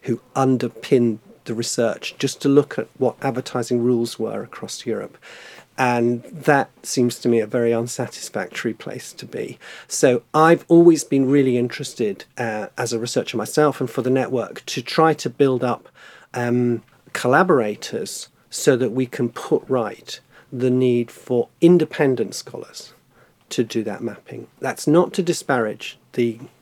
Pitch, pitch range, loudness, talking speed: 125 Hz, 120-140 Hz, -20 LUFS, 150 wpm